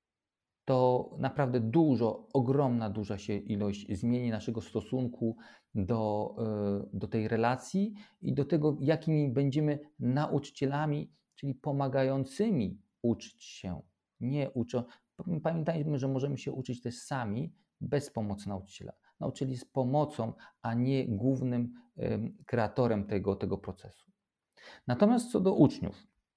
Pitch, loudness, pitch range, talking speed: 130 Hz, -32 LUFS, 110-145 Hz, 115 wpm